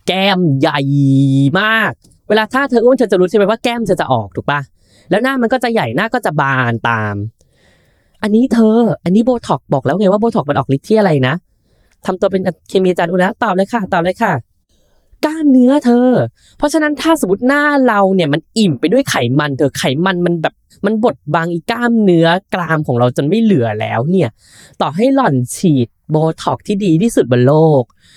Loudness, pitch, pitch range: -13 LUFS, 180 Hz, 140-225 Hz